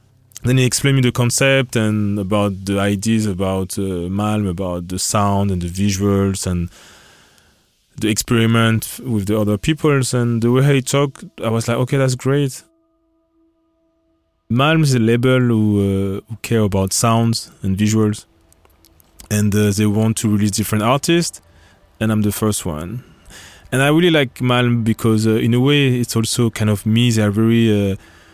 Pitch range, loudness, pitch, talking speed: 100-125 Hz, -17 LUFS, 110 Hz, 170 wpm